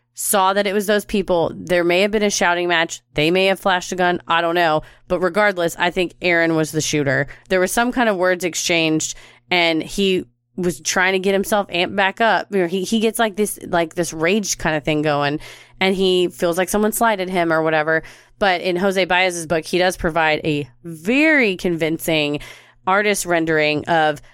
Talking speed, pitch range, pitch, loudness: 200 wpm, 160-195 Hz, 175 Hz, -18 LUFS